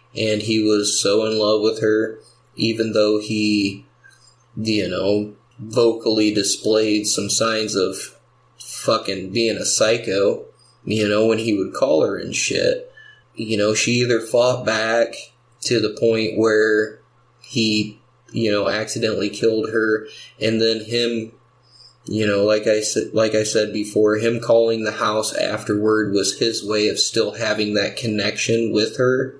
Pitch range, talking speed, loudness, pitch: 105-115 Hz, 155 wpm, -19 LUFS, 110 Hz